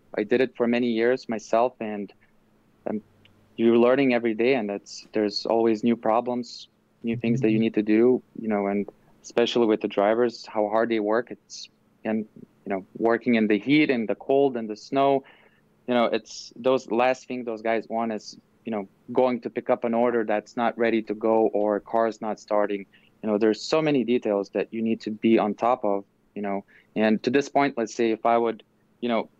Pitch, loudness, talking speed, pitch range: 115 Hz, -24 LUFS, 215 wpm, 105-120 Hz